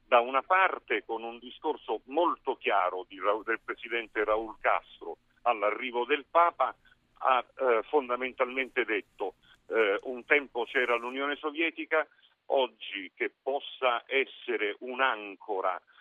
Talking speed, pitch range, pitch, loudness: 115 wpm, 120-165 Hz, 130 Hz, -30 LUFS